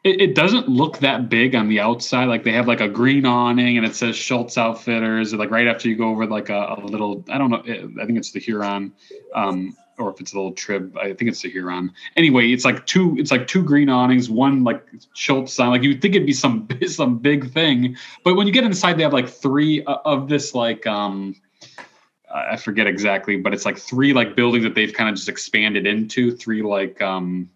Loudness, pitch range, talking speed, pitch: -19 LUFS, 105-135 Hz, 235 wpm, 120 Hz